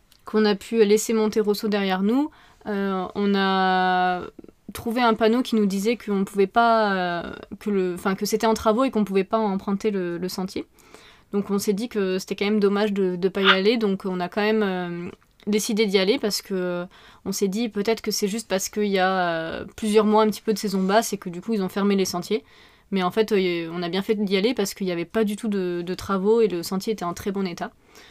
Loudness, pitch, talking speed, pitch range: -23 LUFS, 205 Hz, 250 wpm, 190-220 Hz